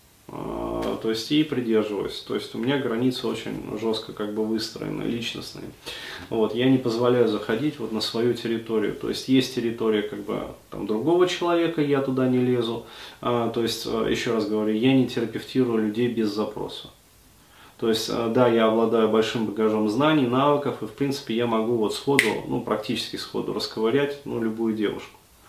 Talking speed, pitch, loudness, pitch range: 165 wpm, 115 Hz, -24 LUFS, 110-130 Hz